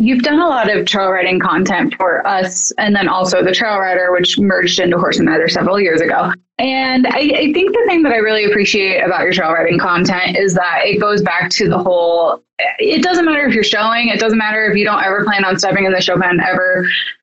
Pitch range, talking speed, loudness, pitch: 185-230 Hz, 240 wpm, -13 LUFS, 195 Hz